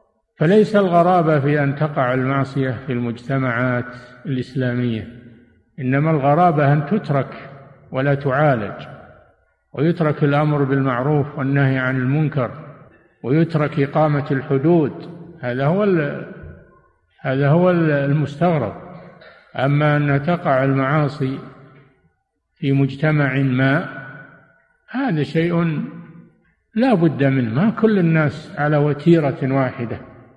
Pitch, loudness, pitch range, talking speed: 140 Hz, -18 LUFS, 130-155 Hz, 95 wpm